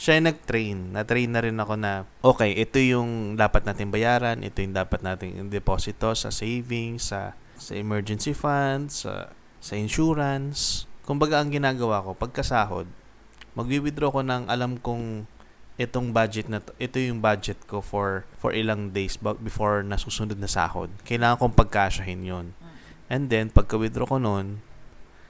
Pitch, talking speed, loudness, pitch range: 110 Hz, 150 wpm, -26 LUFS, 105-125 Hz